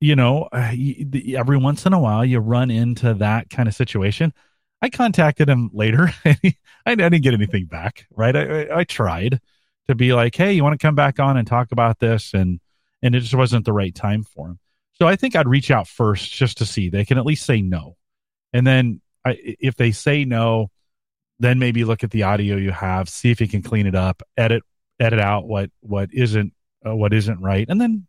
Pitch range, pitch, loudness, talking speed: 105-135 Hz, 120 Hz, -19 LUFS, 220 wpm